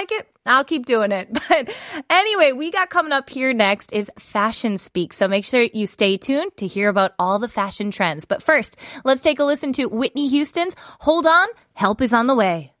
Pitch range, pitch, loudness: 205-305 Hz, 255 Hz, -19 LUFS